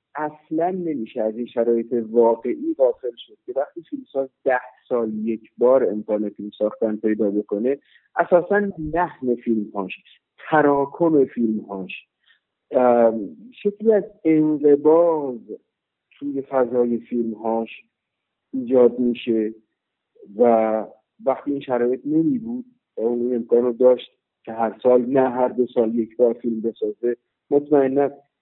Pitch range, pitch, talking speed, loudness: 115-155 Hz, 125 Hz, 120 wpm, -21 LUFS